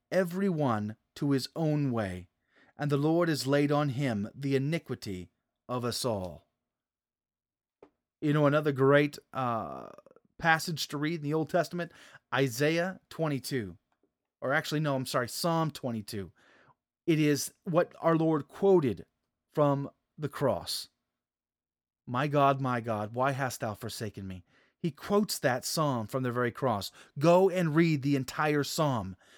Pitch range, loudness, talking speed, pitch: 120-160 Hz, -30 LUFS, 145 wpm, 140 Hz